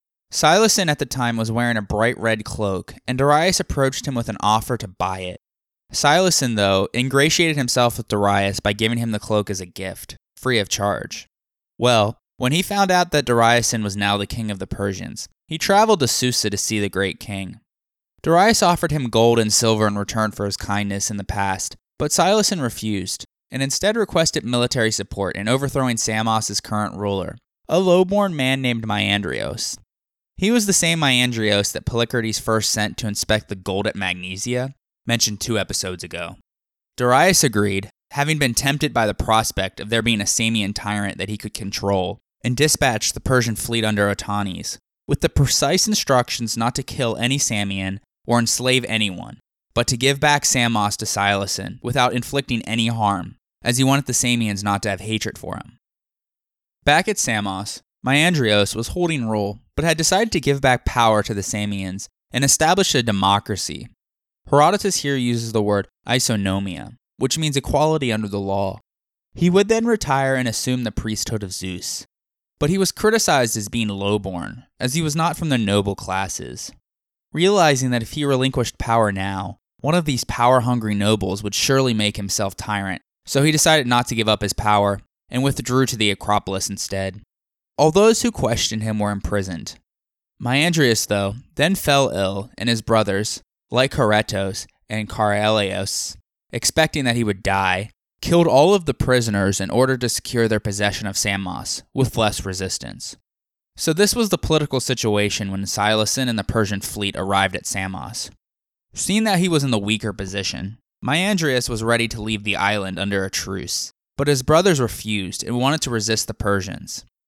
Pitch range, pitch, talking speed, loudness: 100-135 Hz, 110 Hz, 175 wpm, -20 LUFS